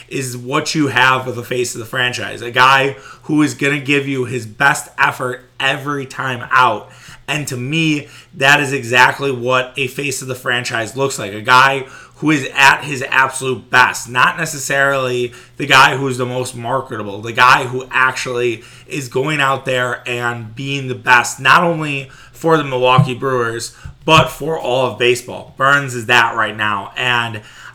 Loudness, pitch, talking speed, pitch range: -15 LUFS, 130 Hz, 180 wpm, 125-140 Hz